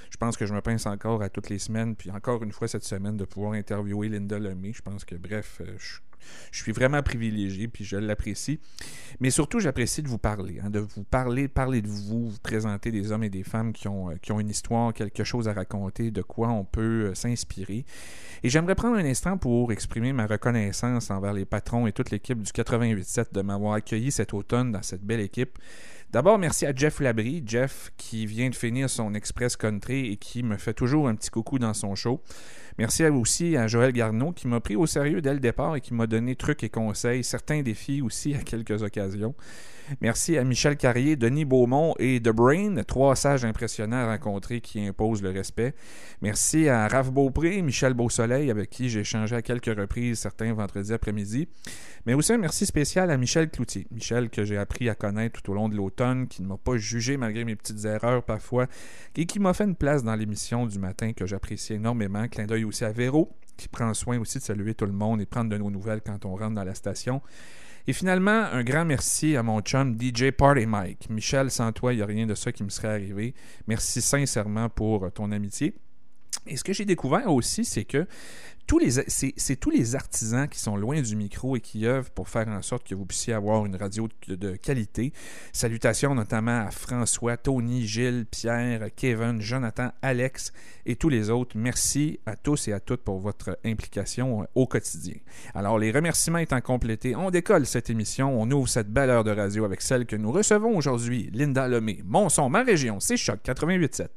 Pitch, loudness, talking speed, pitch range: 115 Hz, -27 LUFS, 210 wpm, 105-130 Hz